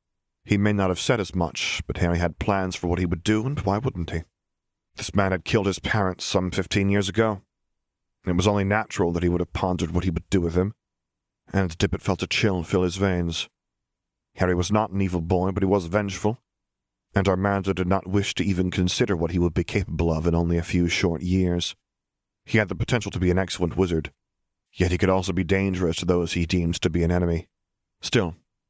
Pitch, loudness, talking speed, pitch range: 95 Hz, -24 LUFS, 225 wpm, 85-100 Hz